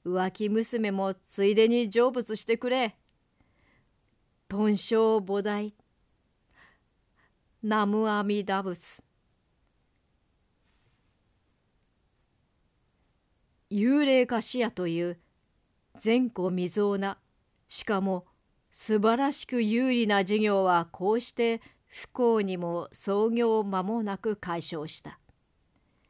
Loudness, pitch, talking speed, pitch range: -28 LUFS, 205 Hz, 160 characters per minute, 175-225 Hz